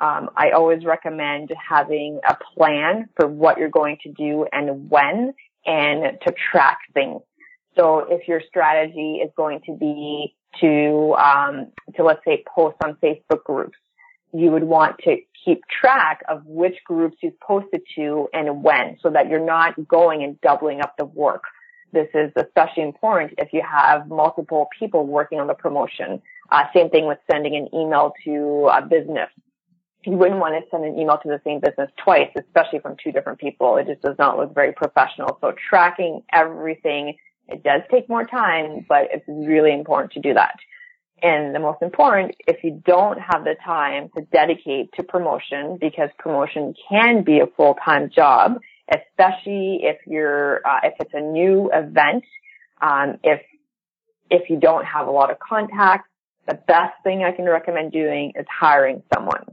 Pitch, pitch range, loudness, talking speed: 160 Hz, 150-185 Hz, -19 LUFS, 175 wpm